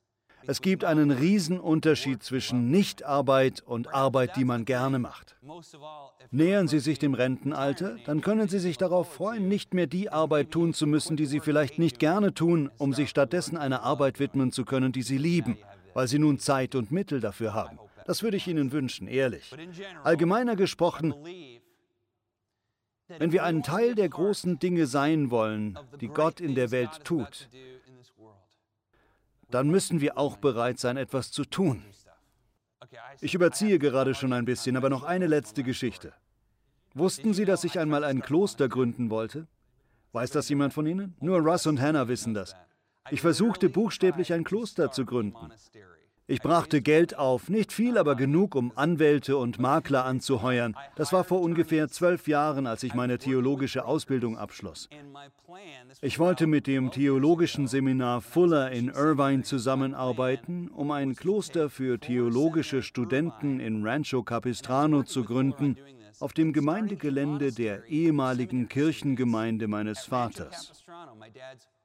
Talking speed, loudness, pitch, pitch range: 150 wpm, -27 LUFS, 140 Hz, 125-160 Hz